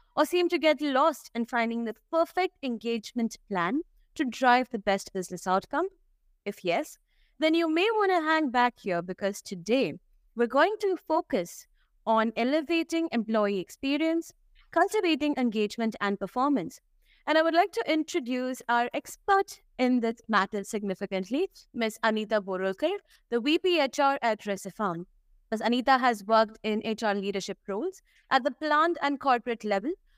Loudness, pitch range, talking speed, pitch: -28 LUFS, 215-315 Hz, 150 wpm, 250 Hz